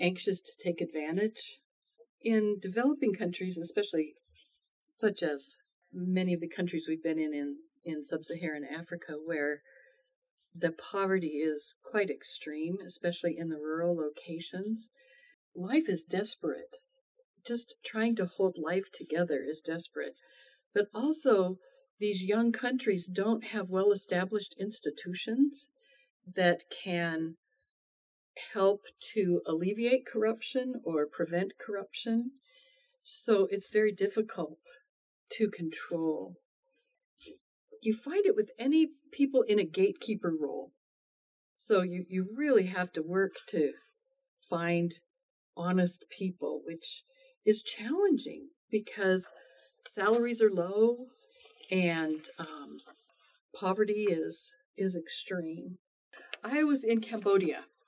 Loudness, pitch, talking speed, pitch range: -32 LUFS, 200 Hz, 110 wpm, 170-245 Hz